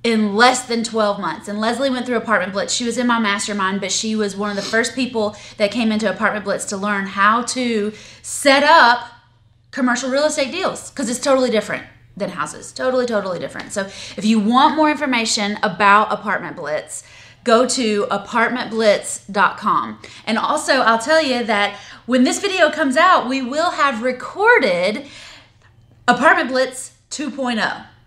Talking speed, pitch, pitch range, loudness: 165 wpm, 235 Hz, 210-260 Hz, -17 LUFS